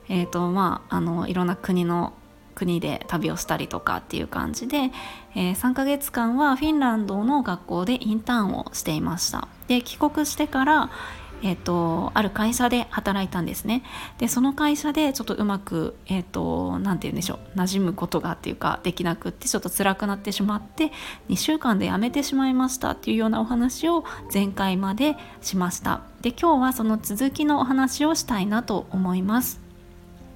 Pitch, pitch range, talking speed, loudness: 220 Hz, 185-265 Hz, 345 characters per minute, -24 LUFS